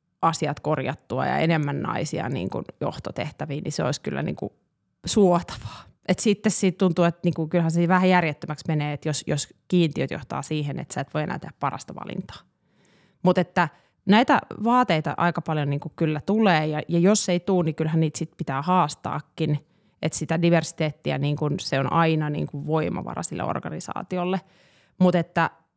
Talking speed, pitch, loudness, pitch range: 180 wpm, 165 Hz, -24 LUFS, 150-180 Hz